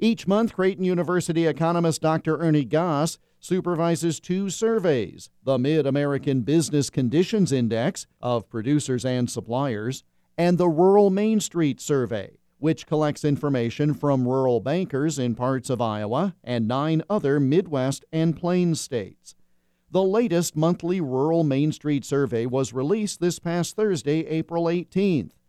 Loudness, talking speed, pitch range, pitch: -23 LUFS, 135 wpm, 135-175 Hz, 155 Hz